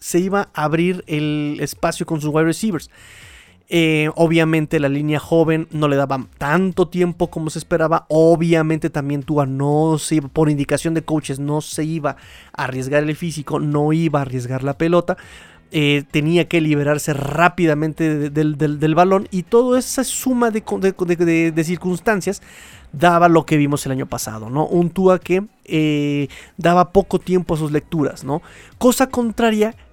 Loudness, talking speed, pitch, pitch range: -18 LUFS, 175 wpm, 160 Hz, 150-175 Hz